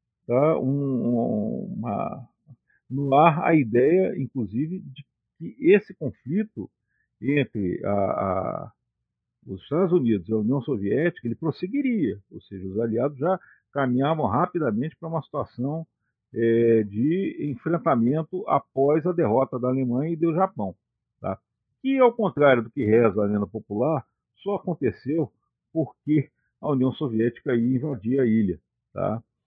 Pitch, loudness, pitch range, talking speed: 135 Hz, -24 LUFS, 115-160 Hz, 130 wpm